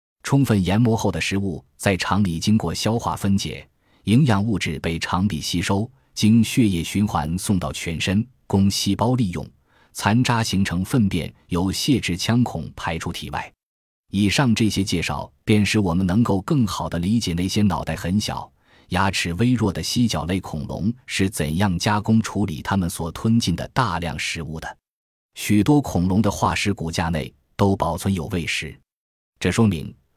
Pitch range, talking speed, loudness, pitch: 85-110 Hz, 250 characters per minute, -21 LUFS, 100 Hz